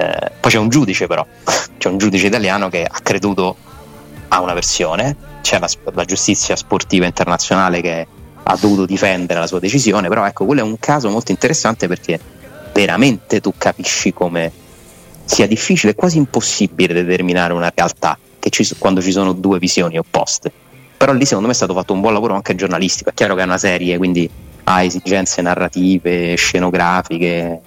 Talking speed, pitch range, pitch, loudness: 170 wpm, 90-100 Hz, 90 Hz, -15 LUFS